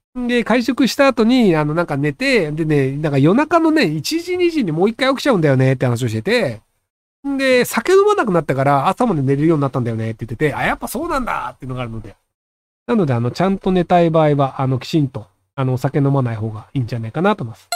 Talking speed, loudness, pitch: 485 characters per minute, -17 LUFS, 155 Hz